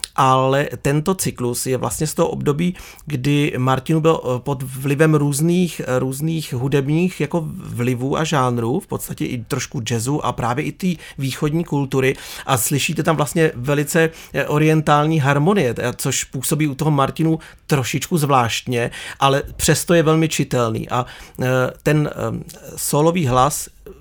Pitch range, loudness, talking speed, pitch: 130-160 Hz, -19 LUFS, 135 wpm, 145 Hz